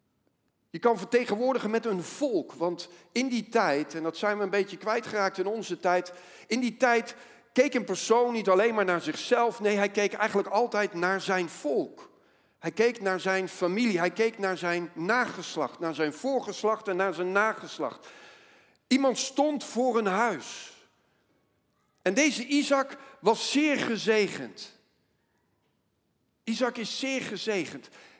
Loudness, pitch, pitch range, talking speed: -28 LUFS, 215 Hz, 185-240 Hz, 150 wpm